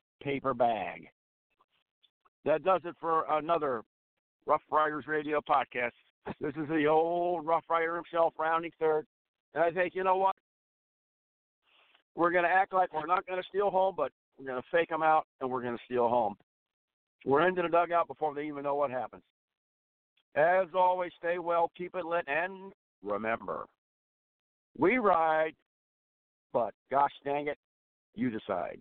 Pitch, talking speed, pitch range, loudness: 160 Hz, 160 wpm, 140-175 Hz, -30 LUFS